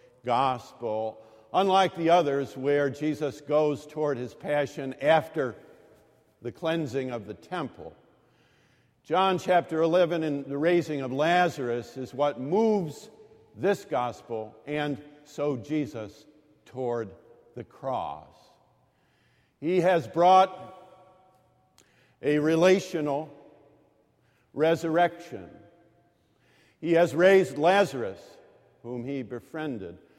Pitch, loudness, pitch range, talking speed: 150 Hz, -27 LUFS, 130-175 Hz, 95 wpm